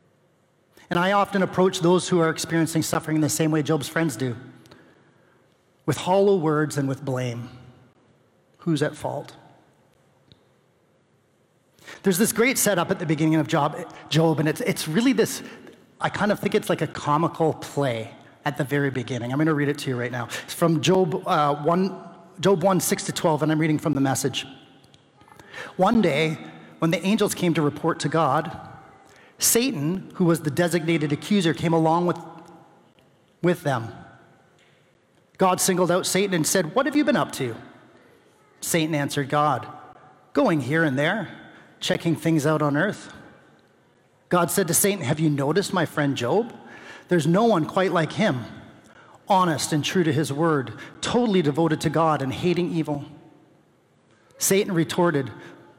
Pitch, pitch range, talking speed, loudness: 165 Hz, 145-180 Hz, 165 wpm, -23 LUFS